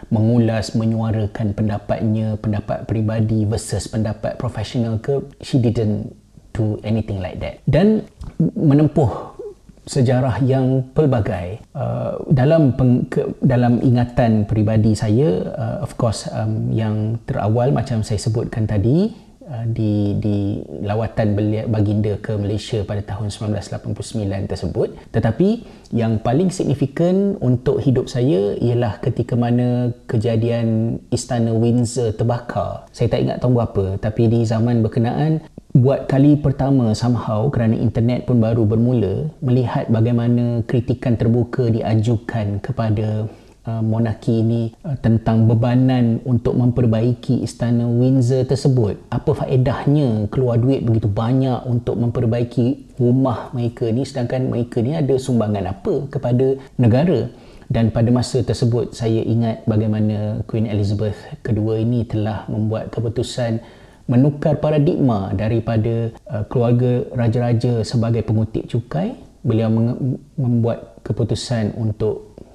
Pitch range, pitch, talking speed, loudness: 110-130 Hz, 115 Hz, 115 wpm, -19 LUFS